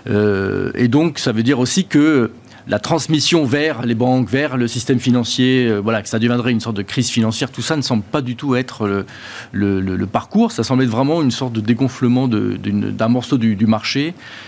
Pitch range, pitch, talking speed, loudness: 115-135 Hz, 125 Hz, 210 wpm, -17 LUFS